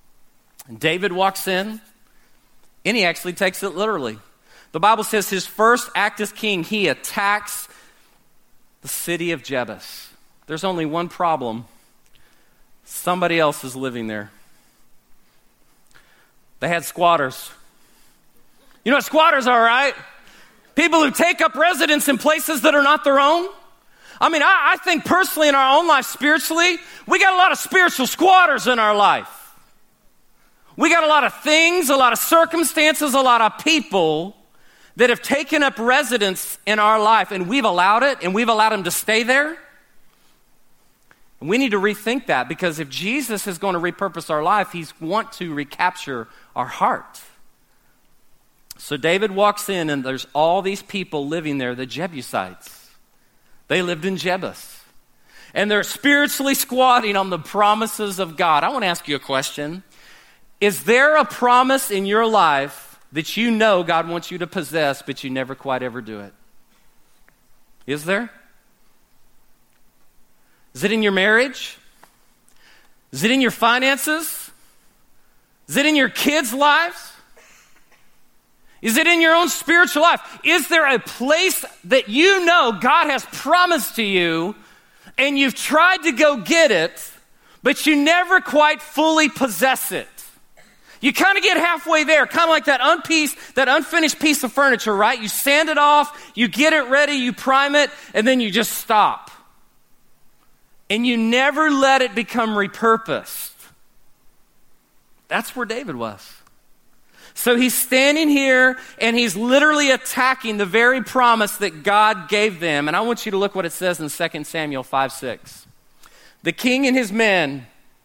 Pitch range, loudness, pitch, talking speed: 180-290 Hz, -17 LUFS, 230 Hz, 160 wpm